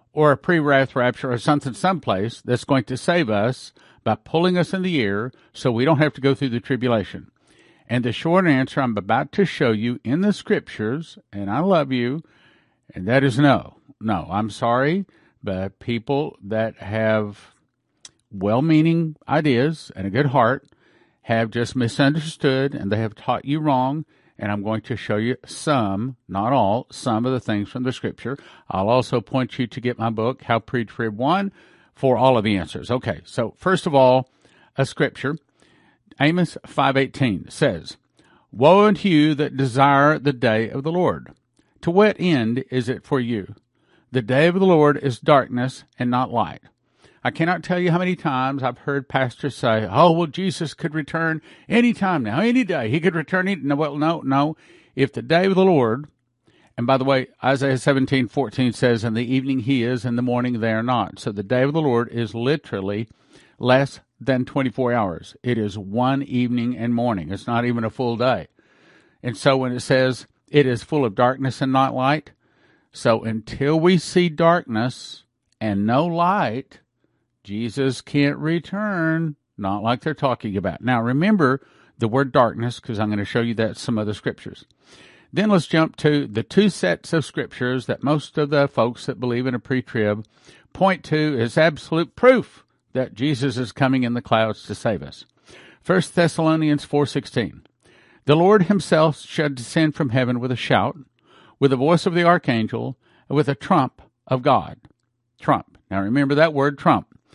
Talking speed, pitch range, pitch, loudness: 185 wpm, 120-150 Hz, 130 Hz, -21 LUFS